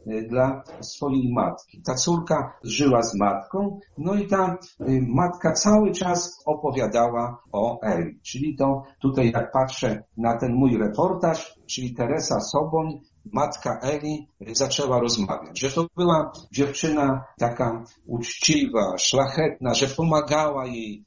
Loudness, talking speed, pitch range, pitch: -24 LUFS, 125 wpm, 120-155 Hz, 135 Hz